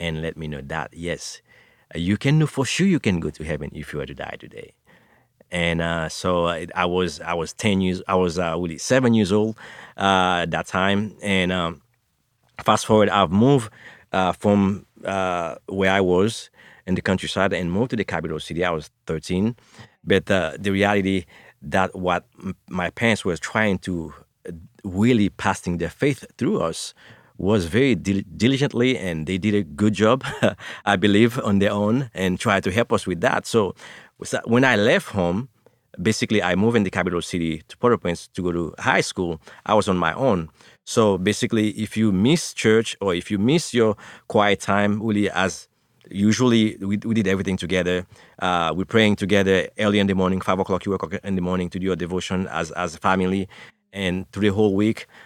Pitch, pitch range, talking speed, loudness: 95 Hz, 90-105 Hz, 195 wpm, -22 LUFS